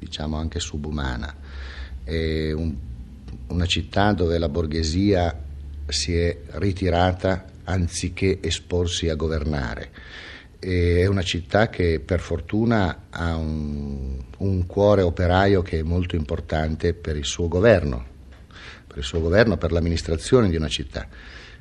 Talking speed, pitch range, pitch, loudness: 125 wpm, 75-90 Hz, 85 Hz, -23 LUFS